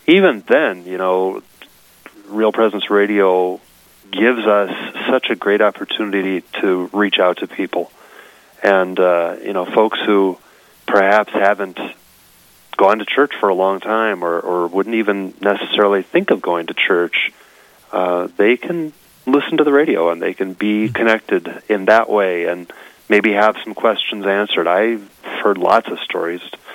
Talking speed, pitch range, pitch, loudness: 155 wpm, 90-110 Hz, 100 Hz, -16 LUFS